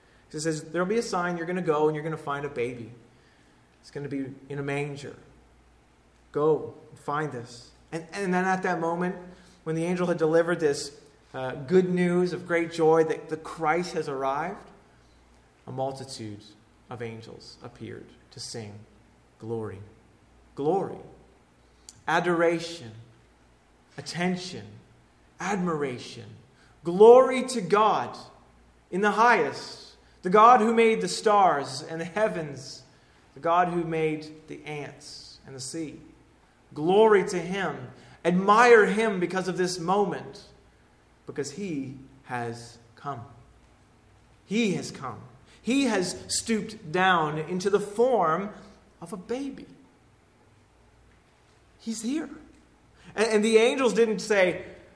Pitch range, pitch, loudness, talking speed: 125-190 Hz, 160 Hz, -25 LUFS, 130 wpm